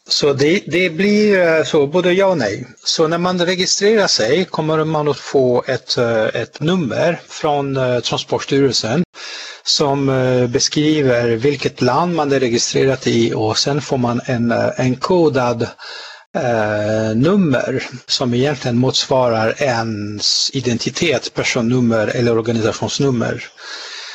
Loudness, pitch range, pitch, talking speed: -16 LUFS, 120-155 Hz, 135 Hz, 120 wpm